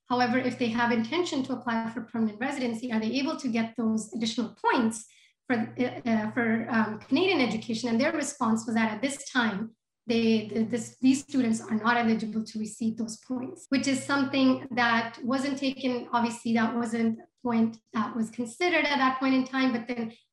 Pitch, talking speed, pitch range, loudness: 240 Hz, 190 wpm, 225-260 Hz, -28 LUFS